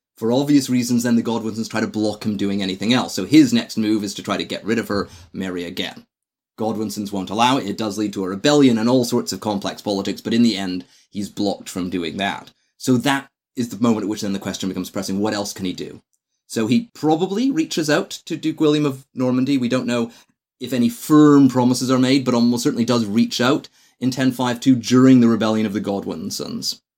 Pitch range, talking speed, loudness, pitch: 105-130 Hz, 225 wpm, -19 LUFS, 120 Hz